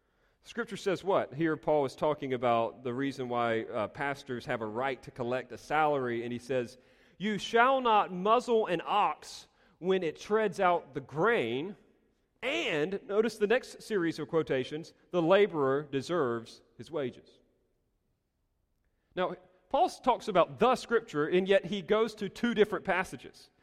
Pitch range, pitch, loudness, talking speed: 130-205 Hz, 160 Hz, -31 LUFS, 155 wpm